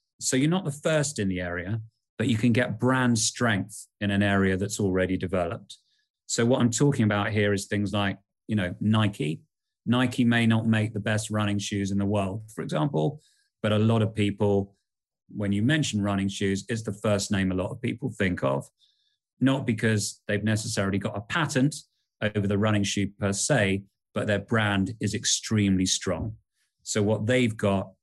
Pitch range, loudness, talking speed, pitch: 100-120 Hz, -26 LUFS, 190 wpm, 105 Hz